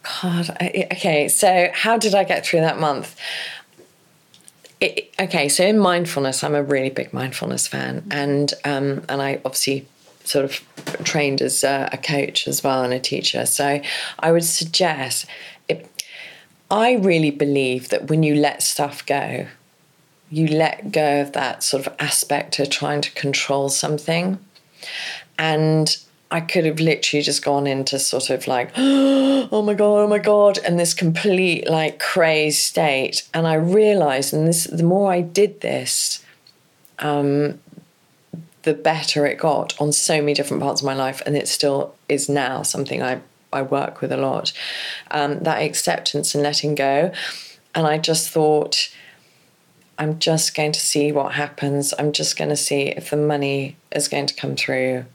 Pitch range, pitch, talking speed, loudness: 140-170 Hz, 150 Hz, 170 wpm, -19 LUFS